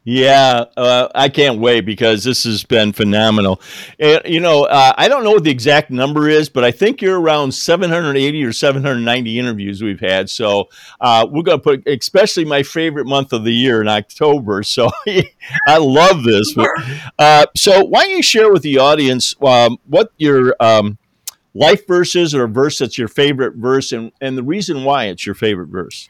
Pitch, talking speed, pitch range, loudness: 135 Hz, 195 wpm, 115-155 Hz, -13 LUFS